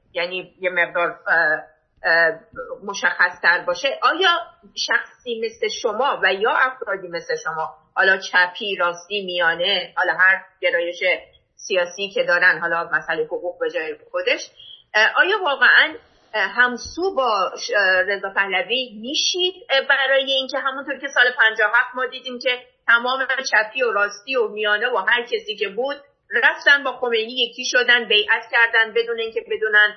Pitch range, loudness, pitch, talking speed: 190-285 Hz, -19 LUFS, 240 Hz, 135 wpm